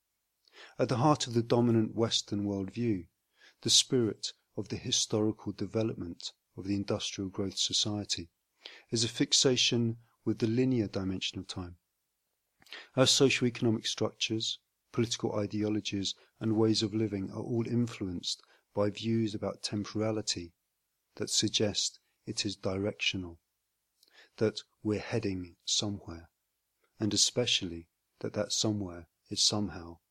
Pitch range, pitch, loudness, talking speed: 95-115 Hz, 105 Hz, -31 LUFS, 120 wpm